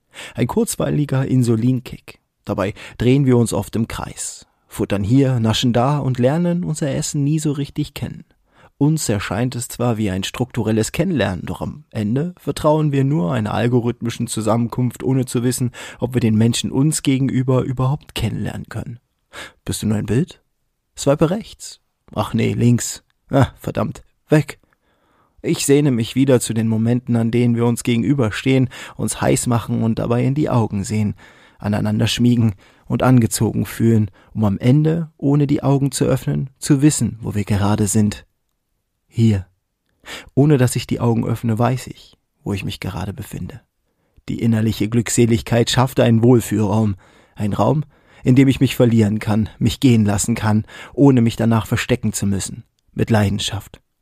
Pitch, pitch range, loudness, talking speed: 120 Hz, 110-130 Hz, -18 LUFS, 160 wpm